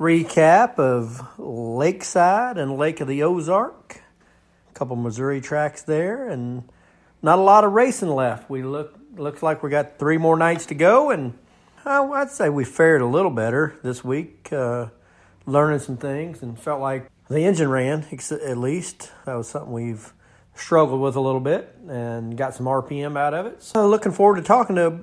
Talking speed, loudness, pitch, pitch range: 185 wpm, -21 LUFS, 145 Hz, 125-165 Hz